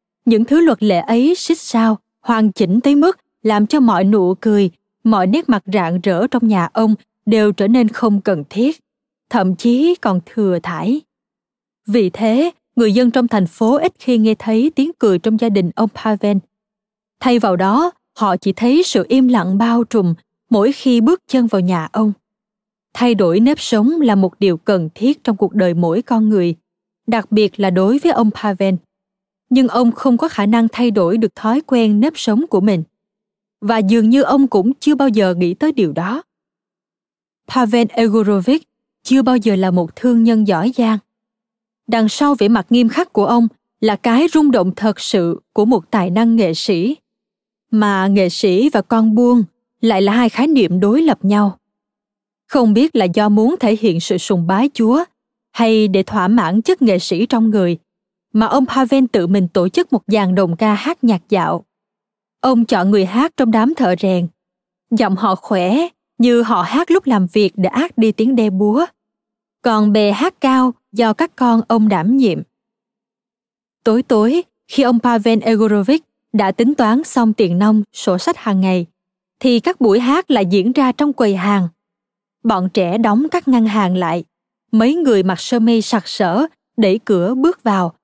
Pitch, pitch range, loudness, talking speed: 225 Hz, 200-250 Hz, -15 LUFS, 190 wpm